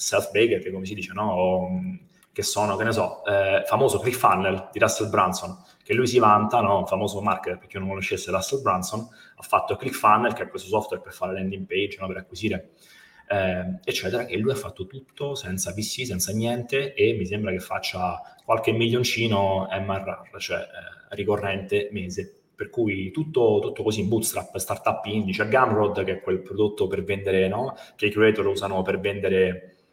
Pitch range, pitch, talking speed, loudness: 95-110 Hz, 100 Hz, 185 wpm, -24 LUFS